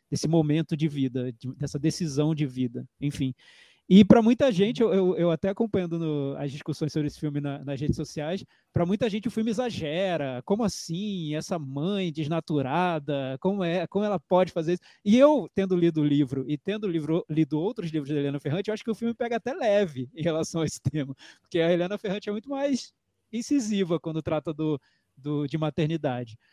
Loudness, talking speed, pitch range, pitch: -27 LUFS, 200 wpm, 150-195 Hz, 165 Hz